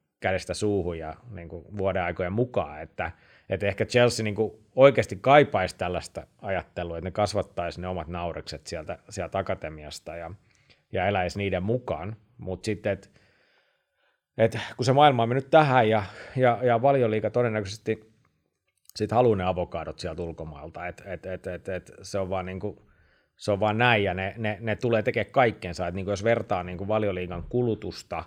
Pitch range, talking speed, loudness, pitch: 90-115 Hz, 165 wpm, -26 LUFS, 100 Hz